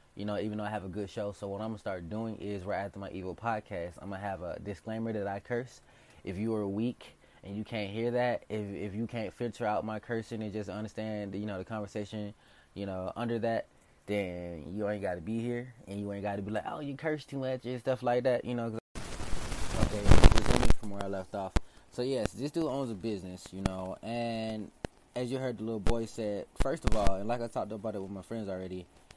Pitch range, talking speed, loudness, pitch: 100-115 Hz, 245 wpm, -35 LUFS, 105 Hz